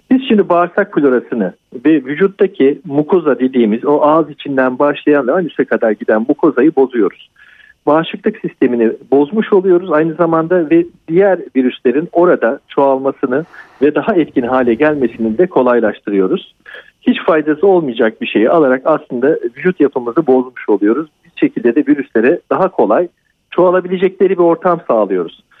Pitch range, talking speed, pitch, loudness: 135-190 Hz, 135 wpm, 160 Hz, -13 LUFS